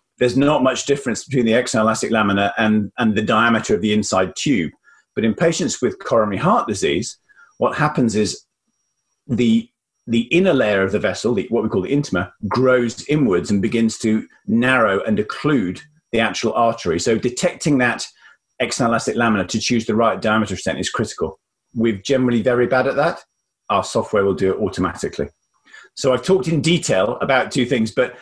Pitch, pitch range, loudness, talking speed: 115 Hz, 105-135 Hz, -18 LUFS, 175 wpm